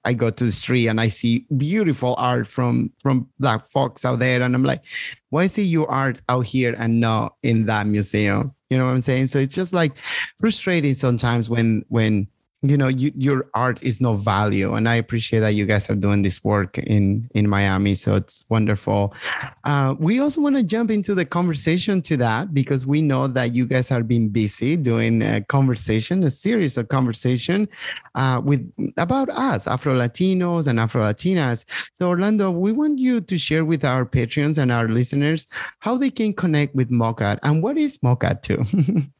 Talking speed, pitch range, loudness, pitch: 195 wpm, 115-155 Hz, -20 LUFS, 130 Hz